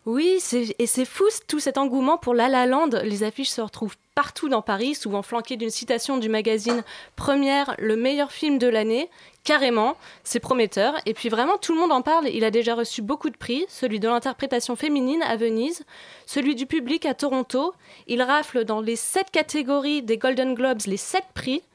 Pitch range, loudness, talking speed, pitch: 230-290 Hz, -23 LUFS, 200 wpm, 260 Hz